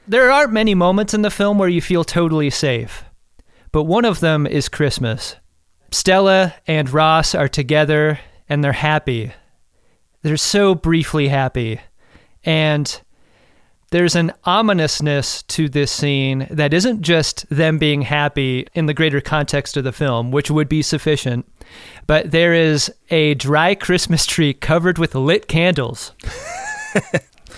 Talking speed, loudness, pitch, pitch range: 140 wpm, -16 LUFS, 155 Hz, 140-170 Hz